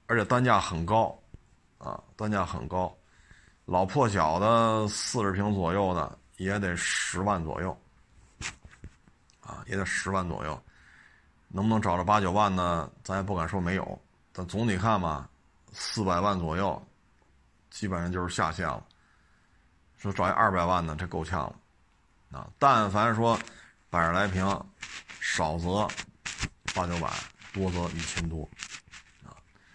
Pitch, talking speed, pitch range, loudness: 95 Hz, 195 characters per minute, 85-105 Hz, -29 LUFS